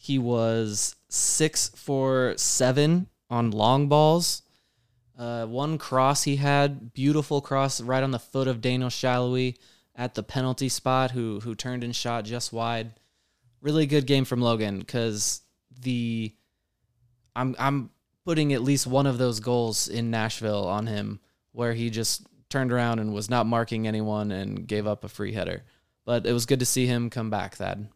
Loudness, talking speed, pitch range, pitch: -26 LUFS, 170 wpm, 110-130 Hz, 120 Hz